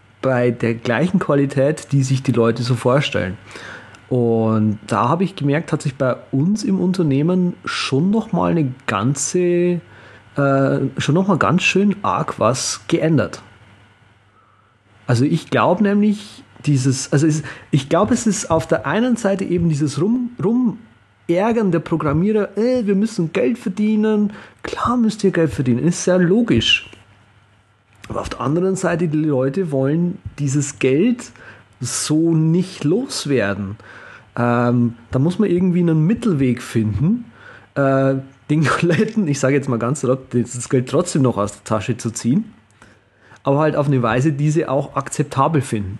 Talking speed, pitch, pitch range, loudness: 155 wpm, 145 Hz, 120-180 Hz, -18 LUFS